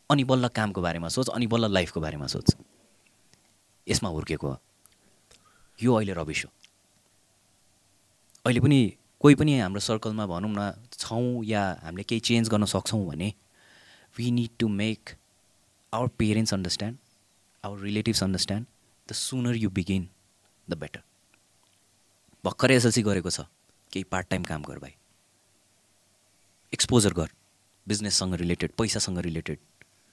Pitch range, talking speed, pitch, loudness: 95-115 Hz, 130 wpm, 100 Hz, -27 LUFS